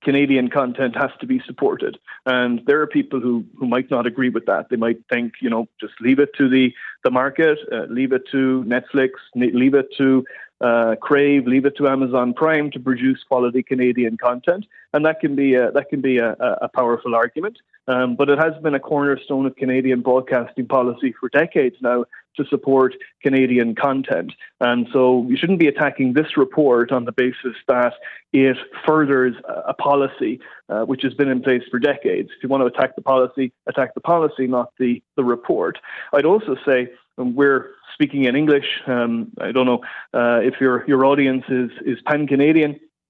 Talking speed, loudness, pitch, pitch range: 190 wpm, -19 LUFS, 130 Hz, 125-140 Hz